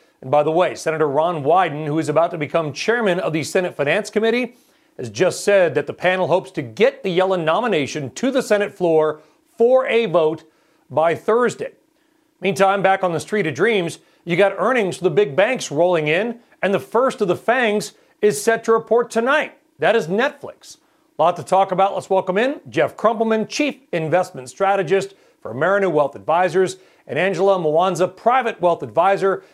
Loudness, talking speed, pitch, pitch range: -19 LUFS, 185 wpm, 190 Hz, 170-225 Hz